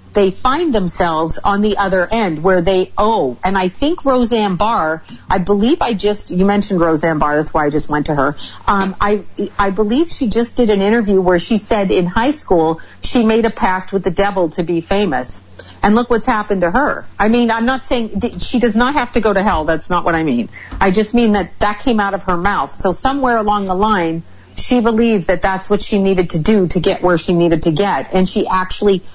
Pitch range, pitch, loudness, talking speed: 180-225 Hz, 200 Hz, -15 LUFS, 235 wpm